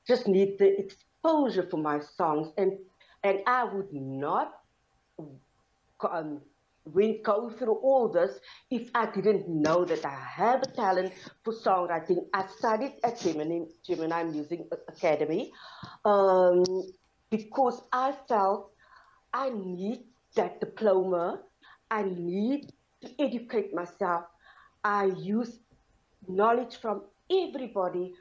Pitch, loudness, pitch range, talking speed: 195 Hz, -29 LUFS, 175-235 Hz, 110 wpm